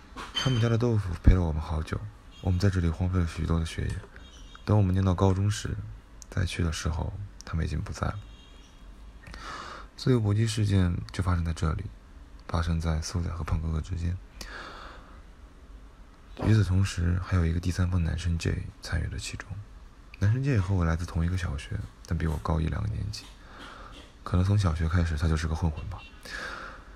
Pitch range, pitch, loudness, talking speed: 80-100 Hz, 90 Hz, -29 LUFS, 275 characters per minute